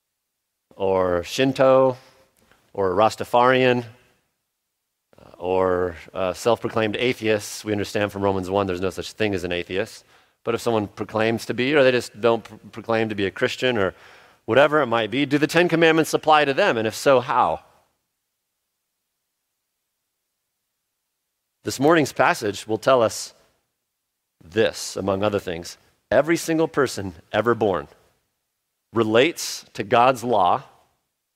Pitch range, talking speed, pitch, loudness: 100-130 Hz, 135 wpm, 115 Hz, -21 LUFS